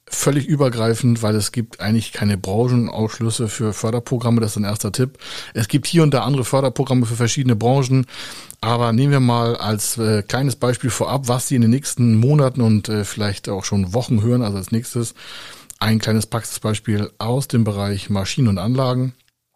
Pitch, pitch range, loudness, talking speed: 120 Hz, 110-130 Hz, -19 LUFS, 180 wpm